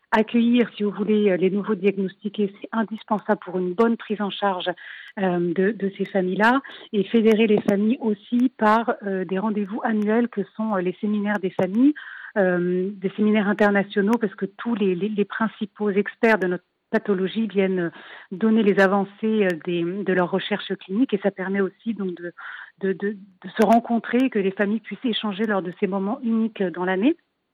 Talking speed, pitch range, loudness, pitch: 180 wpm, 190-220 Hz, -23 LUFS, 205 Hz